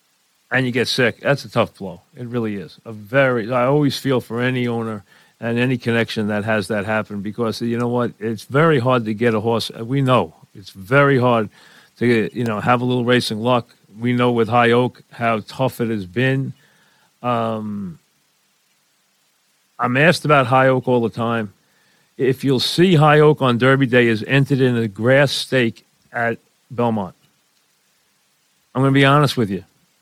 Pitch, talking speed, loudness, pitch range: 120 Hz, 185 wpm, -18 LUFS, 115-130 Hz